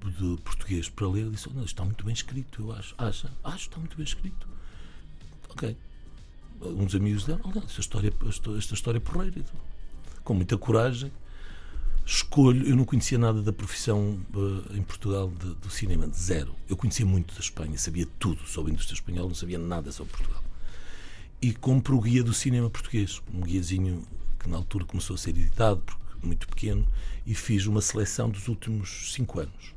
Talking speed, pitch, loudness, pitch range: 185 wpm, 100 Hz, -29 LUFS, 90-115 Hz